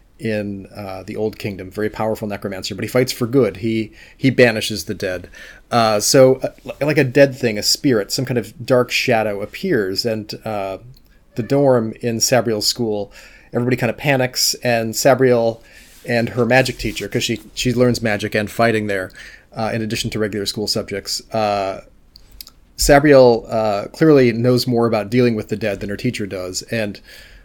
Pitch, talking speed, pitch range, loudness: 115 Hz, 175 wpm, 105-125 Hz, -18 LUFS